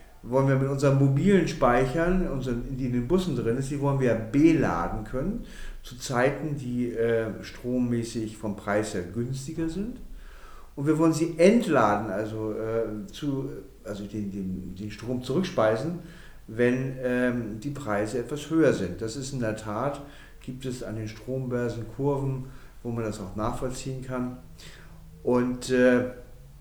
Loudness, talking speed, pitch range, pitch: -27 LUFS, 155 wpm, 110-140 Hz, 125 Hz